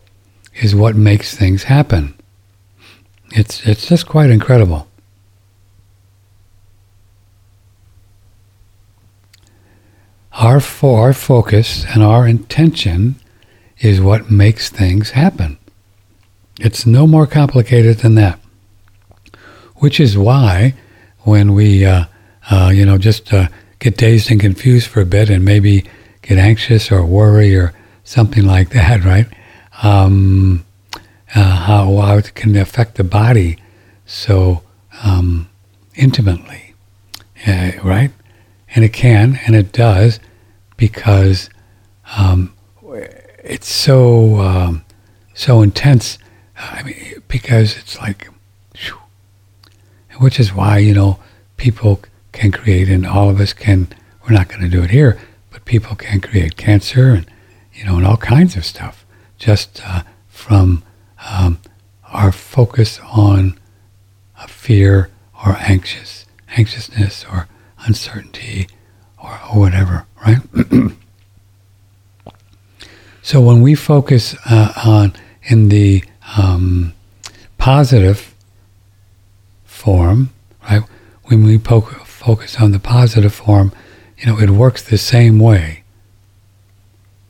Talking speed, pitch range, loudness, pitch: 115 wpm, 100-110 Hz, -12 LUFS, 100 Hz